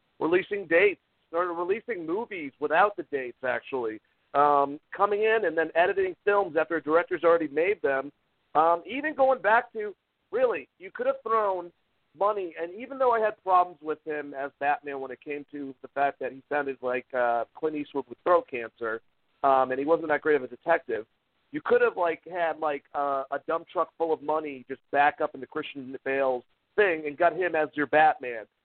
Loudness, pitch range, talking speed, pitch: -27 LUFS, 145-225 Hz, 200 wpm, 165 Hz